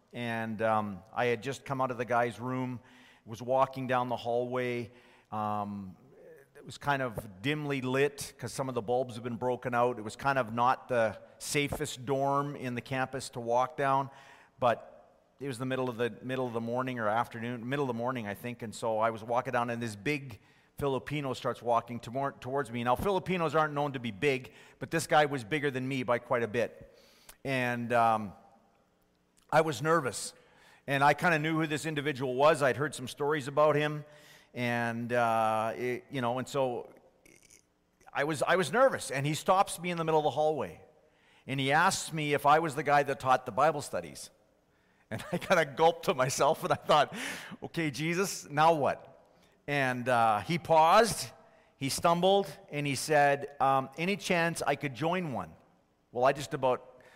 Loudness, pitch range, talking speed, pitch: -30 LUFS, 120-150 Hz, 195 wpm, 135 Hz